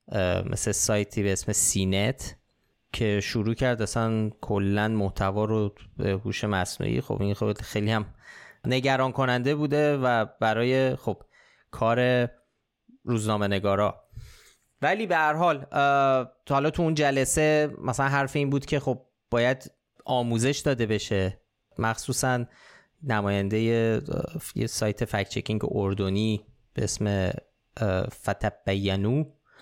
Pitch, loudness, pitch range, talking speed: 115 Hz, -26 LUFS, 105-135 Hz, 115 wpm